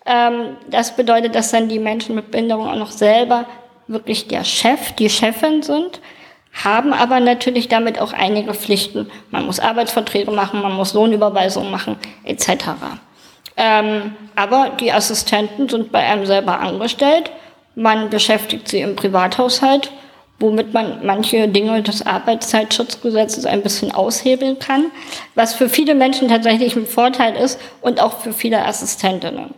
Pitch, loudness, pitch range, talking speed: 230 Hz, -16 LUFS, 215-250 Hz, 140 wpm